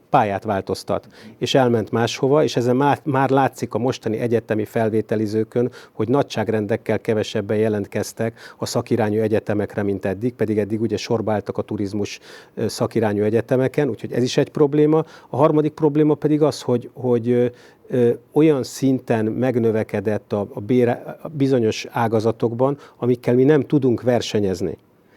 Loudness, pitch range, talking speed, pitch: -20 LUFS, 110-135 Hz, 125 wpm, 120 Hz